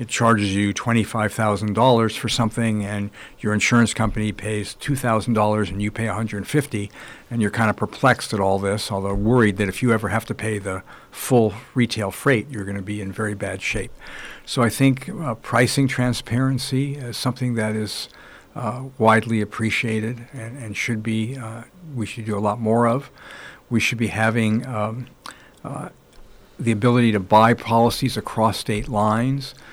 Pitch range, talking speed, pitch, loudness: 105-120 Hz, 170 wpm, 110 Hz, -21 LUFS